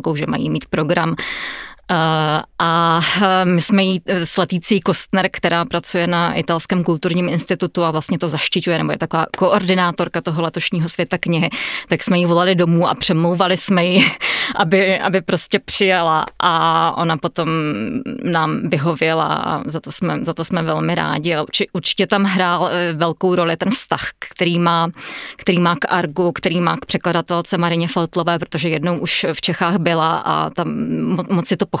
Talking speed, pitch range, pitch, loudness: 165 wpm, 165-185 Hz, 175 Hz, -17 LUFS